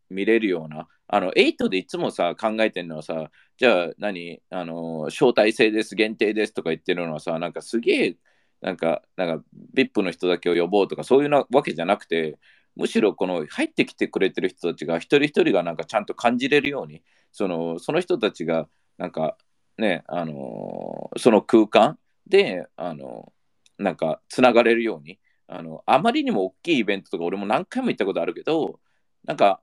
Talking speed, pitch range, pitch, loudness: 360 characters per minute, 85-125 Hz, 105 Hz, -23 LUFS